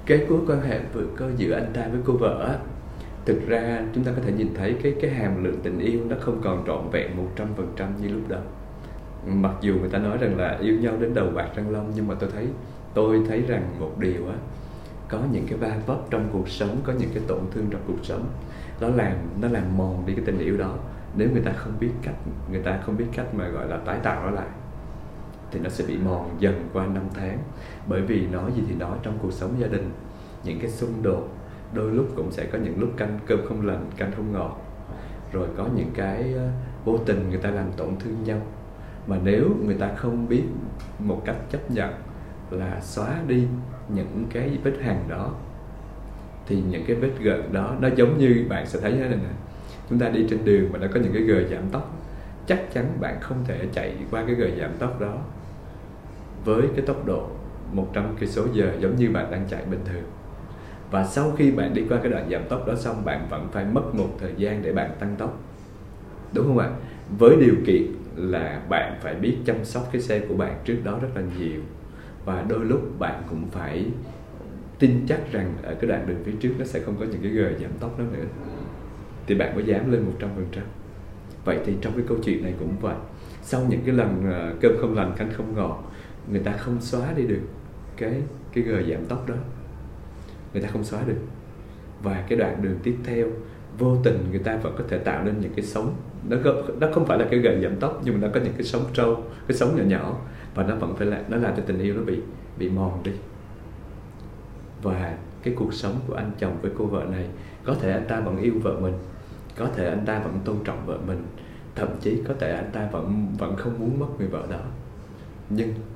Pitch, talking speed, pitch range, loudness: 105 Hz, 230 wpm, 95-120 Hz, -25 LUFS